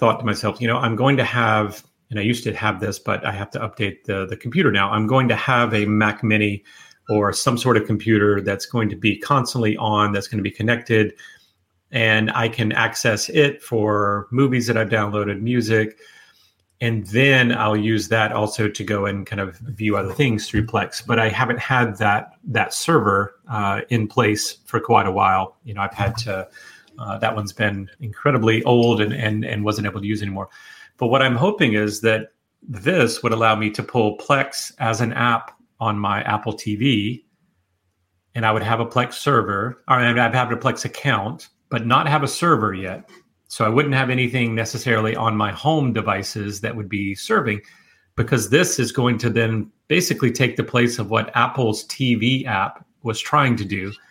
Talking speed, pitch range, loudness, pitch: 200 wpm, 105-120 Hz, -20 LUFS, 110 Hz